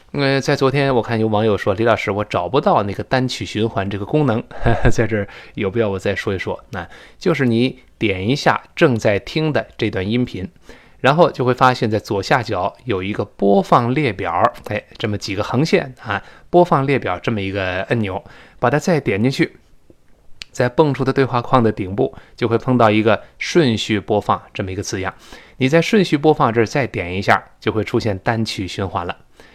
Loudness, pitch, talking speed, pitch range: -18 LUFS, 115 Hz, 290 characters per minute, 105-135 Hz